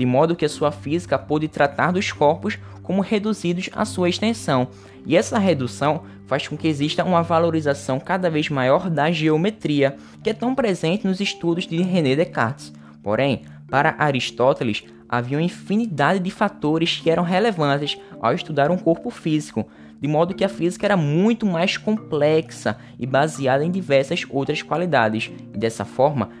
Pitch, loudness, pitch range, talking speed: 155 Hz, -21 LUFS, 130-180 Hz, 165 wpm